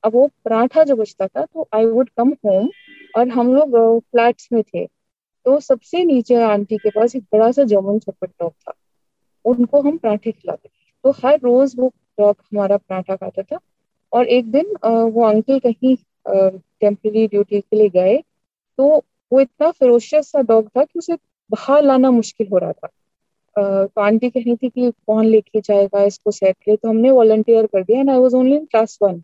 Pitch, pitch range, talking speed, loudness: 230 Hz, 210-265 Hz, 185 wpm, -16 LUFS